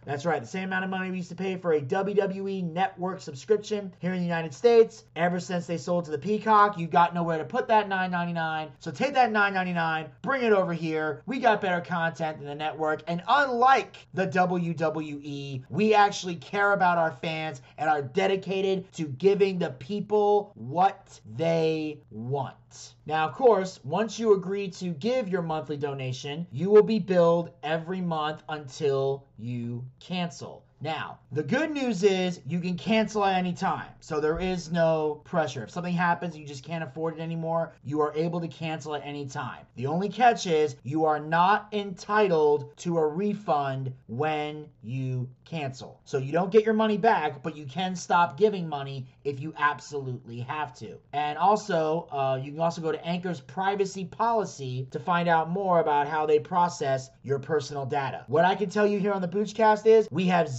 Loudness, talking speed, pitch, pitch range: -27 LUFS, 190 wpm, 165 Hz, 150-195 Hz